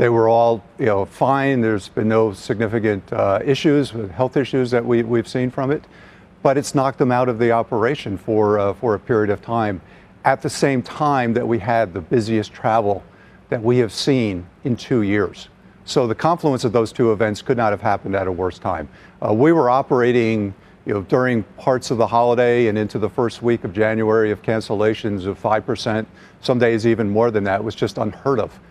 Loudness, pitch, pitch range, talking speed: -19 LUFS, 115 Hz, 105-125 Hz, 210 wpm